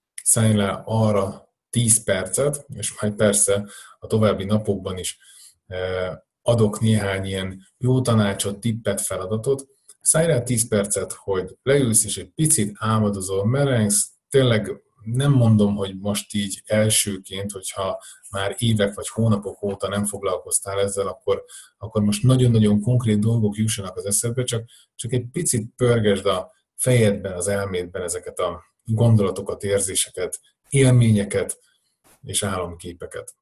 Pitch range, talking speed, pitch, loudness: 100-125 Hz, 130 wpm, 110 Hz, -21 LUFS